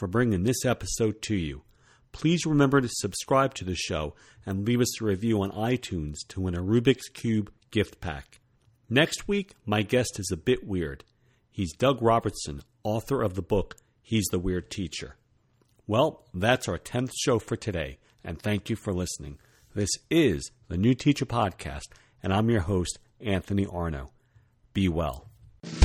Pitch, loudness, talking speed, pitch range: 110 Hz, -28 LUFS, 165 wpm, 95-120 Hz